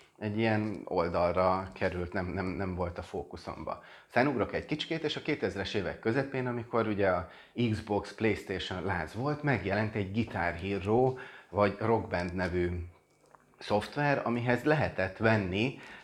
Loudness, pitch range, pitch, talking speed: -32 LUFS, 95-120 Hz, 105 Hz, 140 wpm